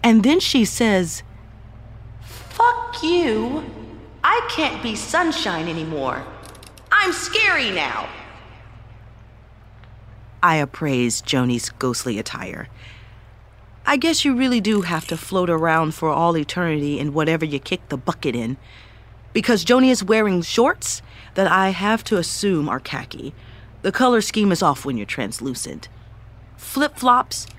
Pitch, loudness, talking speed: 145 Hz, -20 LUFS, 130 wpm